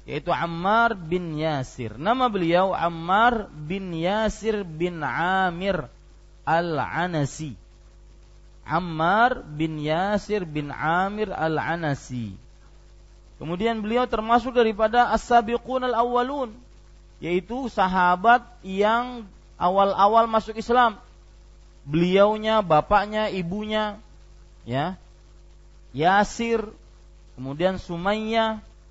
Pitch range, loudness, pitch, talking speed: 150-220 Hz, -23 LUFS, 180 Hz, 75 wpm